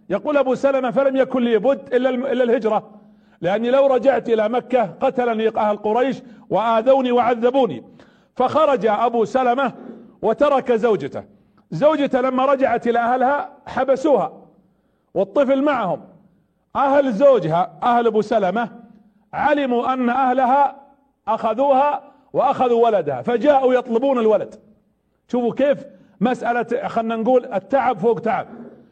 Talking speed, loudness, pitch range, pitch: 115 wpm, -19 LUFS, 225-270 Hz, 245 Hz